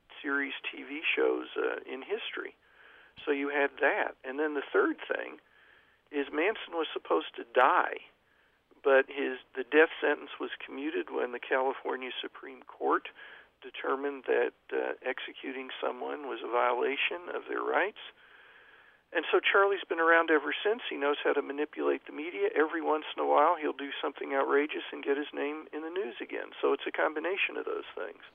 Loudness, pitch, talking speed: -31 LUFS, 340 Hz, 175 wpm